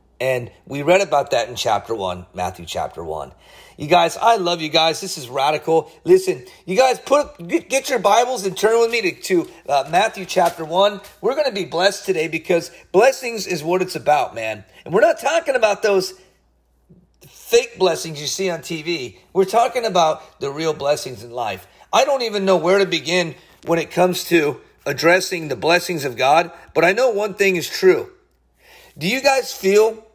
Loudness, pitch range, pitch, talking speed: -19 LUFS, 160-230 Hz, 185 Hz, 195 wpm